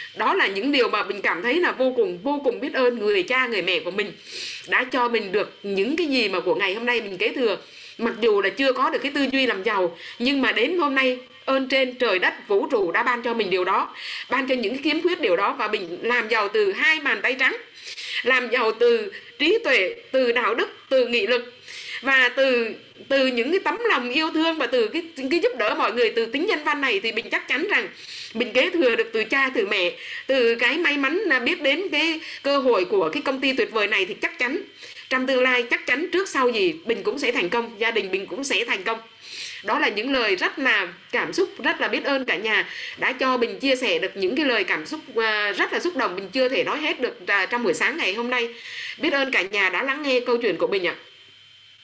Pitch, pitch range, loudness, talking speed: 275 Hz, 250-380 Hz, -22 LUFS, 255 wpm